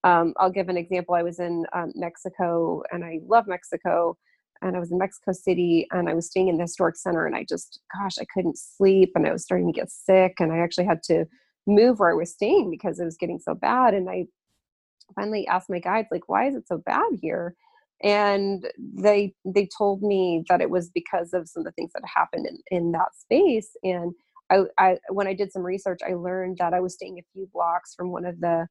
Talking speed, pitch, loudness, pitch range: 235 wpm, 180 Hz, -24 LUFS, 175-195 Hz